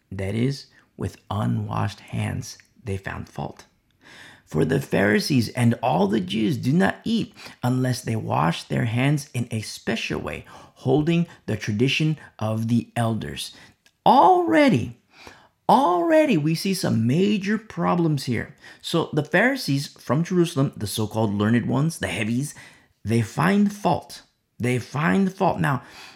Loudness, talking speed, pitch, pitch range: -23 LUFS, 135 wpm, 130 Hz, 115-165 Hz